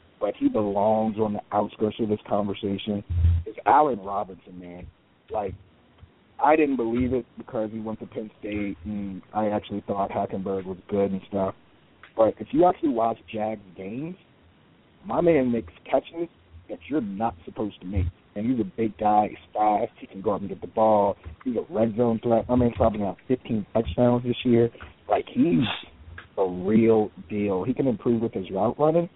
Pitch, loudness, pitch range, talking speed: 105 Hz, -25 LUFS, 100-115 Hz, 185 wpm